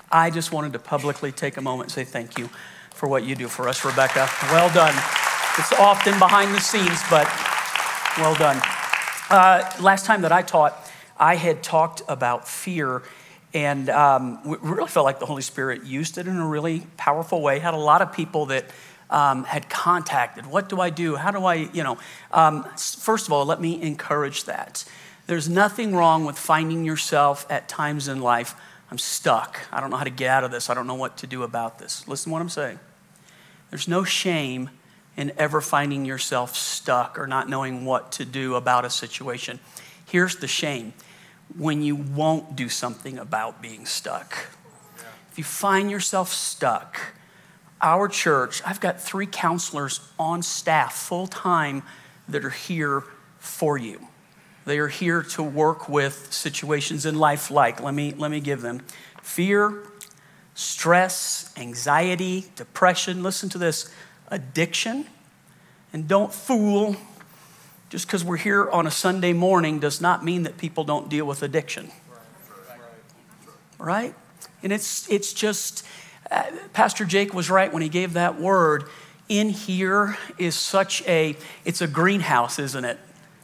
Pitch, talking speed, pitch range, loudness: 160 Hz, 170 wpm, 140-180 Hz, -22 LUFS